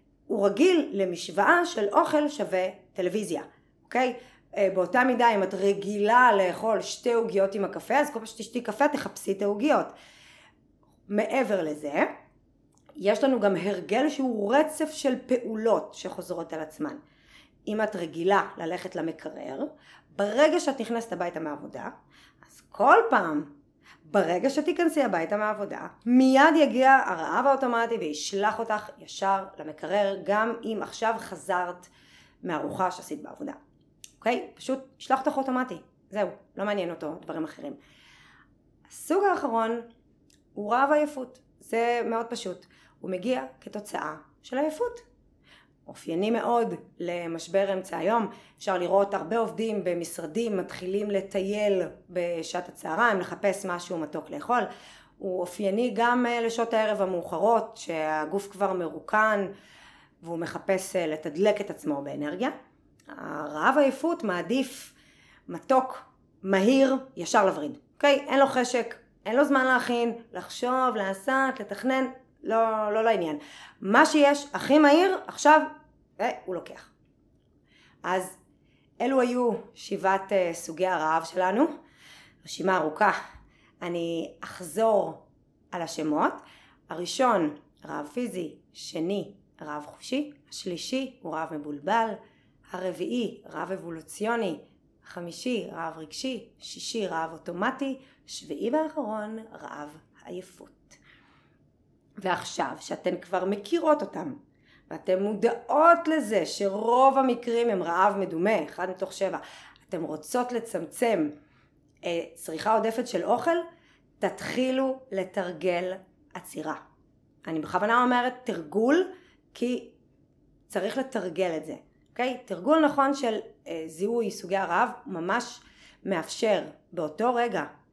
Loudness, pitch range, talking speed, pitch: -27 LUFS, 180-255 Hz, 115 wpm, 210 Hz